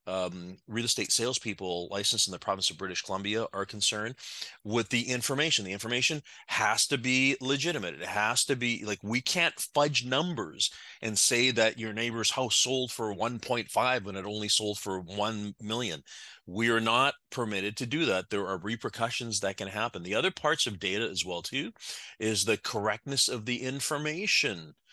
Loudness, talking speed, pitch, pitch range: -29 LUFS, 180 wpm, 115 Hz, 100-130 Hz